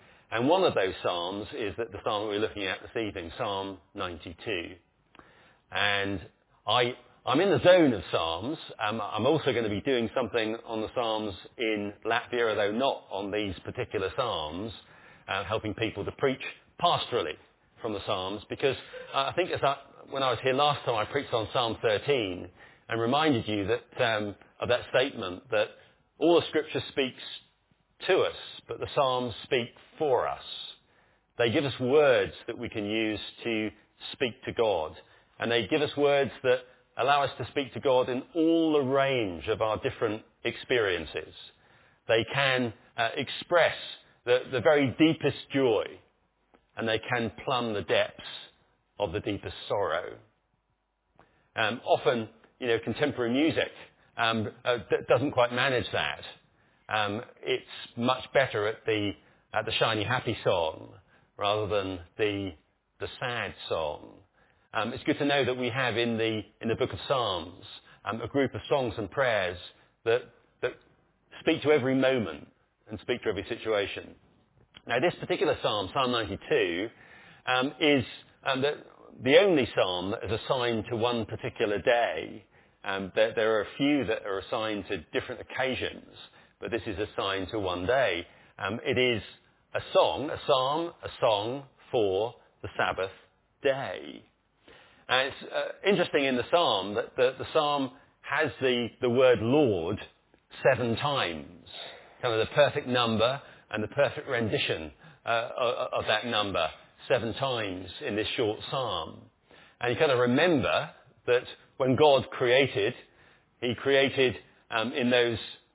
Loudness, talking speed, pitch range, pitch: -28 LUFS, 160 wpm, 105-145 Hz, 120 Hz